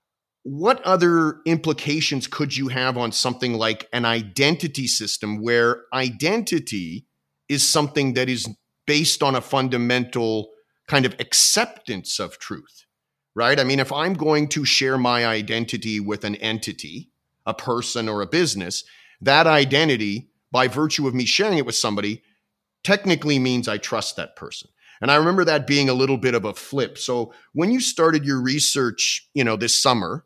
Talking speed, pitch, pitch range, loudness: 165 wpm, 130 Hz, 115-150 Hz, -20 LUFS